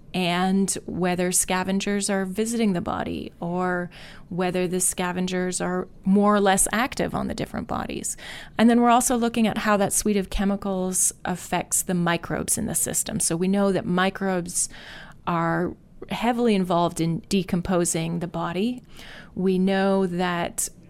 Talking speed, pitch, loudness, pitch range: 150 wpm, 185 Hz, -23 LUFS, 175-200 Hz